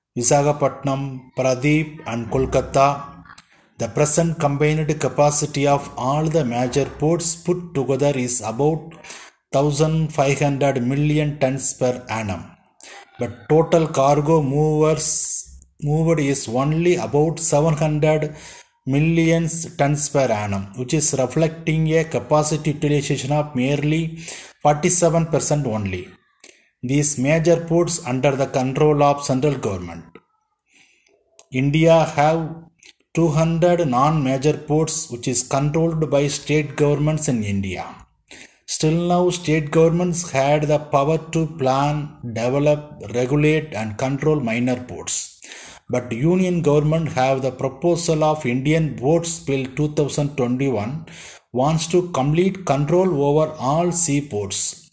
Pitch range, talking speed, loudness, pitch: 135-160 Hz, 110 wpm, -19 LUFS, 150 Hz